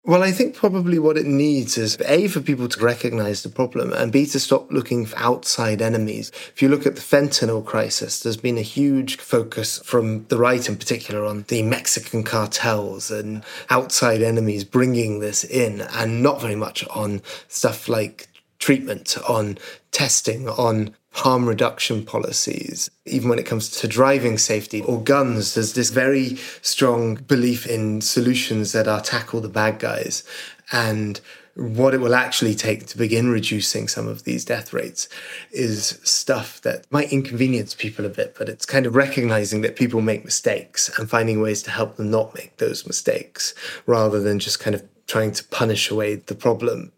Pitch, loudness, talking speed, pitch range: 115 Hz, -21 LUFS, 175 wpm, 110-130 Hz